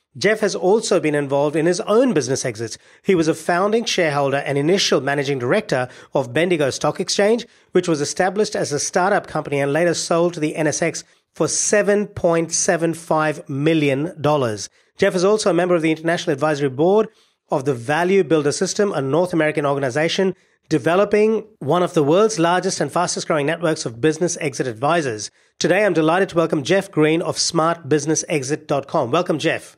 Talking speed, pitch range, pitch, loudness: 165 wpm, 150-185 Hz, 165 Hz, -19 LUFS